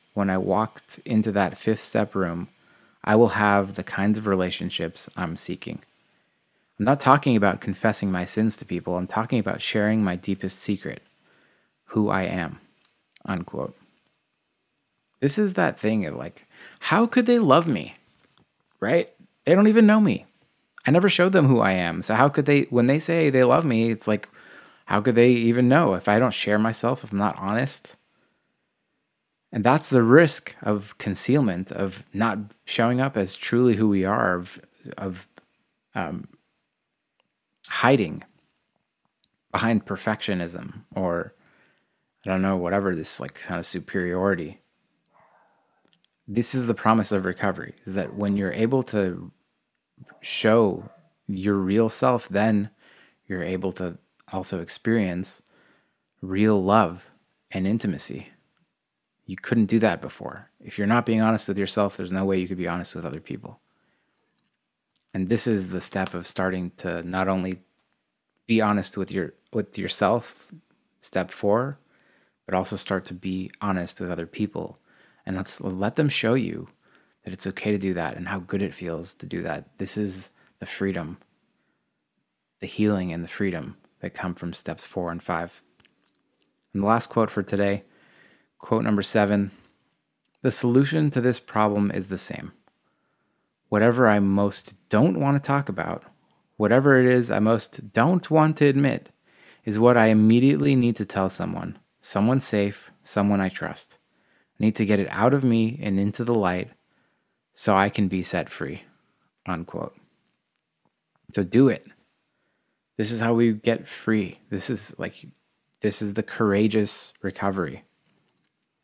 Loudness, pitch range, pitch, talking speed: -23 LUFS, 95-115 Hz, 105 Hz, 160 wpm